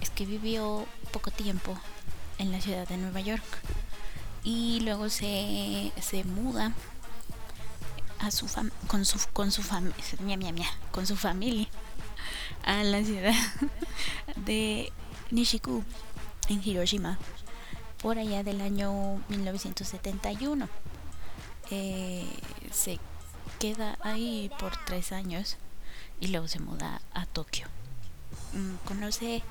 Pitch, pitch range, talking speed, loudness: 195 Hz, 175-215 Hz, 115 wpm, -33 LUFS